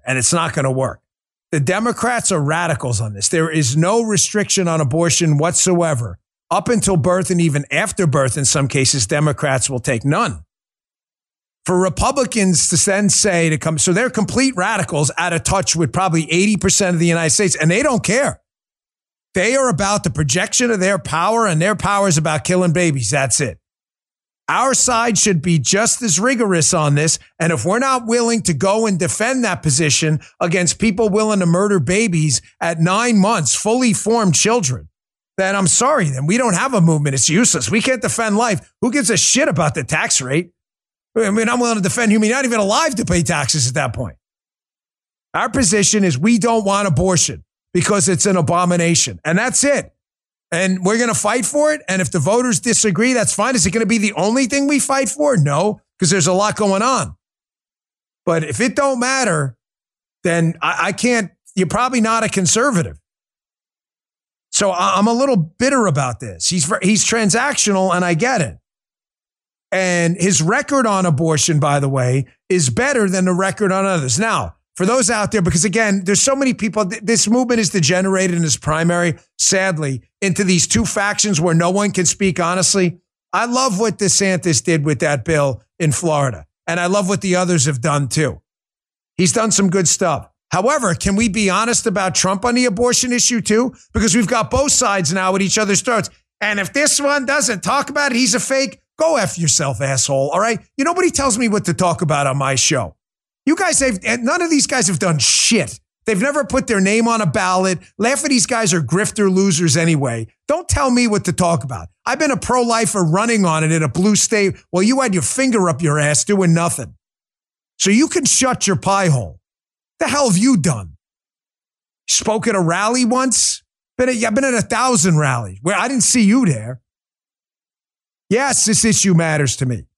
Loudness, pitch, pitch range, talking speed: -16 LUFS, 190 Hz, 165-225 Hz, 200 wpm